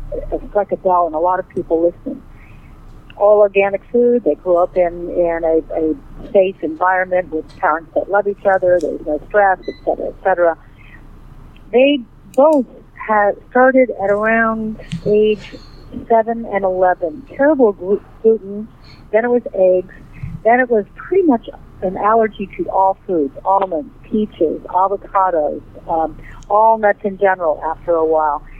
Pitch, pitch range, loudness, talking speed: 190 Hz, 165-220 Hz, -16 LUFS, 150 wpm